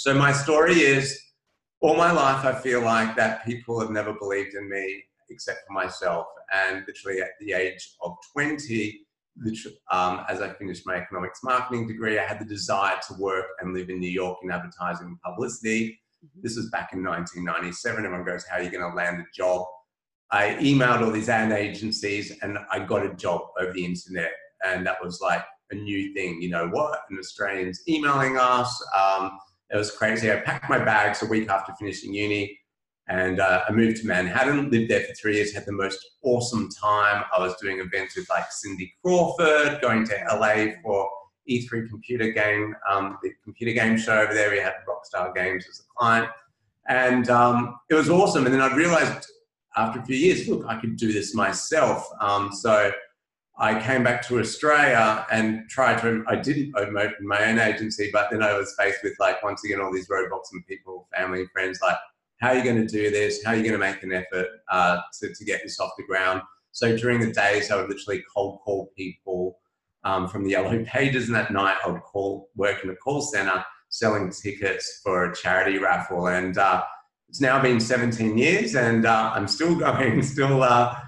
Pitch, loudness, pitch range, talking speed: 105 Hz, -24 LUFS, 95-120 Hz, 200 wpm